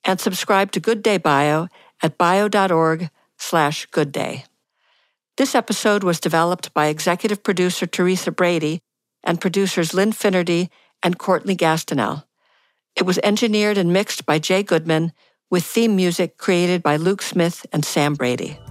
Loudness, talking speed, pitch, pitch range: -19 LUFS, 140 wpm, 180 Hz, 160-195 Hz